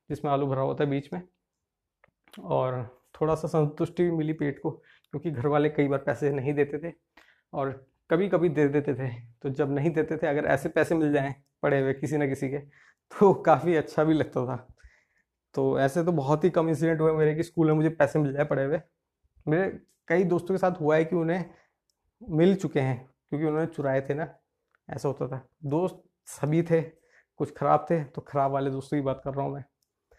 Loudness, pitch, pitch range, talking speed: -27 LUFS, 150 Hz, 140-165 Hz, 210 wpm